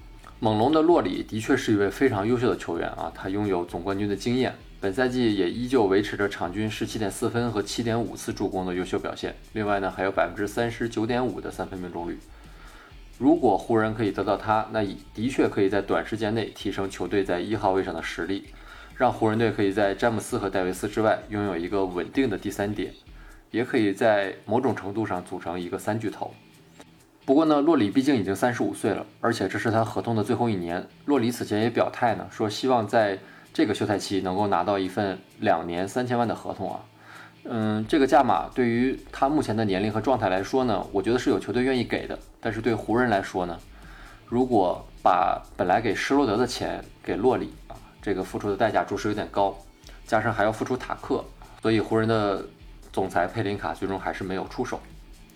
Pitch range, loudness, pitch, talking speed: 95-120 Hz, -26 LUFS, 105 Hz, 320 characters per minute